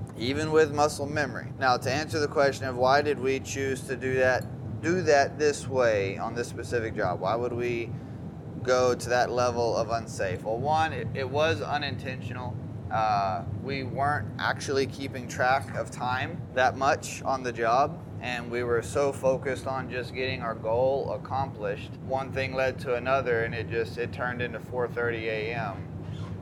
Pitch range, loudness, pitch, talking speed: 115-135 Hz, -28 LUFS, 130 Hz, 175 wpm